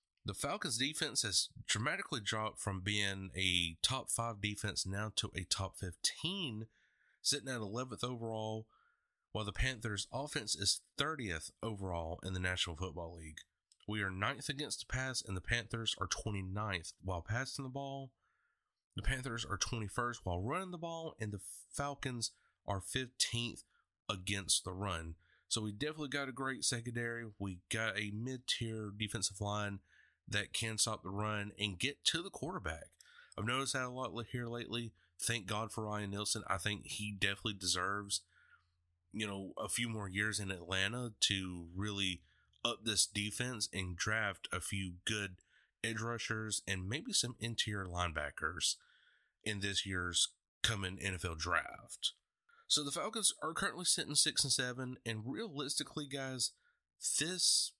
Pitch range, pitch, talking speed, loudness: 95-125 Hz, 110 Hz, 155 wpm, -38 LUFS